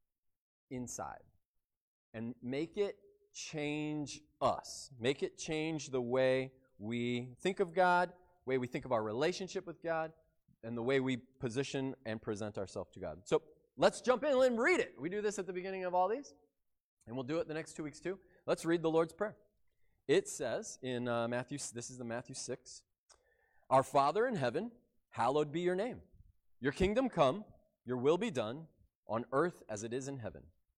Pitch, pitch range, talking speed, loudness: 145 Hz, 125-180 Hz, 185 wpm, -36 LUFS